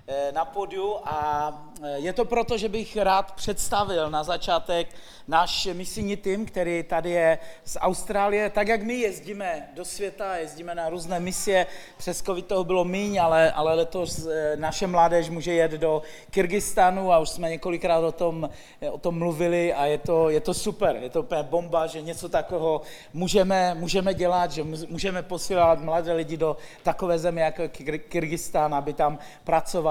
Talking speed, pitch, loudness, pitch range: 165 wpm, 170 Hz, -25 LUFS, 160-190 Hz